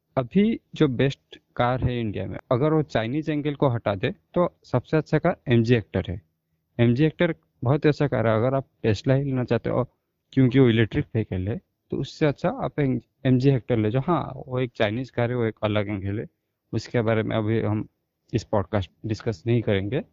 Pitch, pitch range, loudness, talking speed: 120 Hz, 110-140 Hz, -24 LUFS, 220 wpm